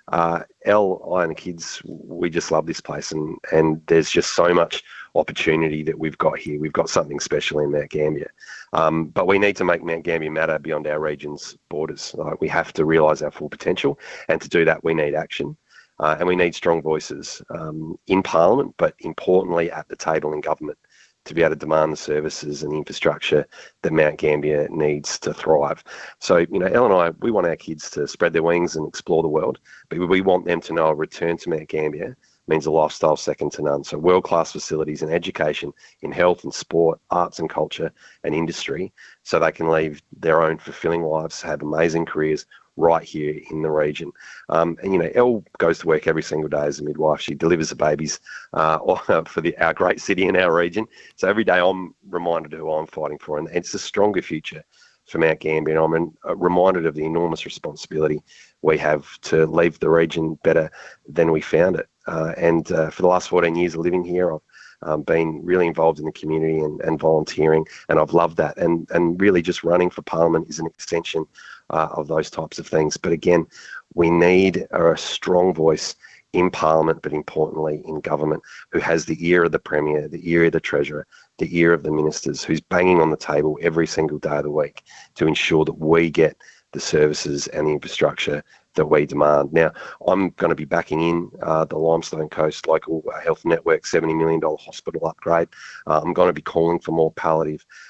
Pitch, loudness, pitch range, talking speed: 80 Hz, -21 LUFS, 75-85 Hz, 210 wpm